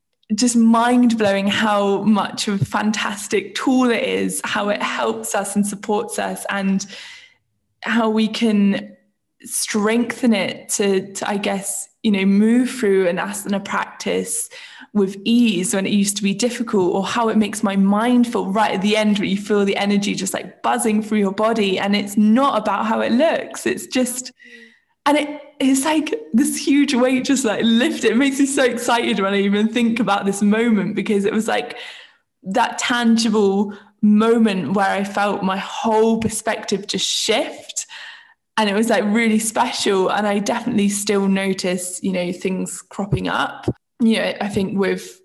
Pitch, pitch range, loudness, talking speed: 215 Hz, 200-240 Hz, -19 LUFS, 175 wpm